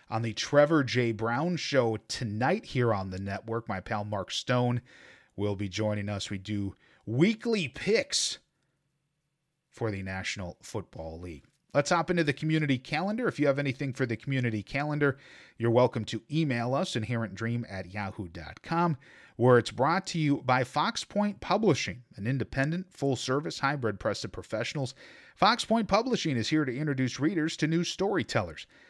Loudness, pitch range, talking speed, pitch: -29 LUFS, 110-150 Hz, 160 wpm, 130 Hz